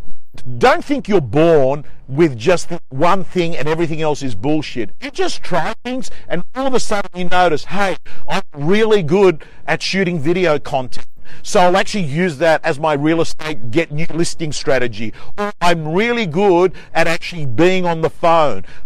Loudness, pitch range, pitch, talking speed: -17 LUFS, 150-190 Hz, 170 Hz, 175 wpm